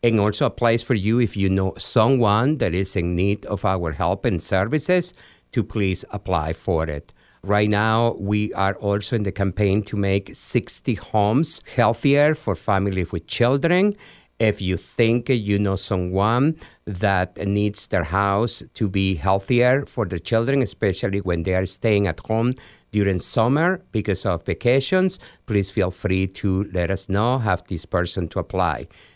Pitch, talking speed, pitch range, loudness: 100 Hz, 165 wpm, 95-115 Hz, -22 LUFS